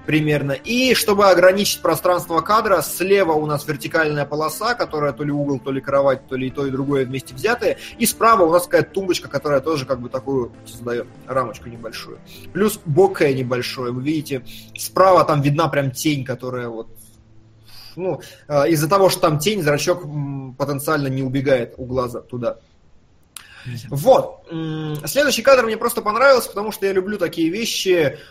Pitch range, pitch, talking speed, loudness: 130-185 Hz, 150 Hz, 165 wpm, -19 LUFS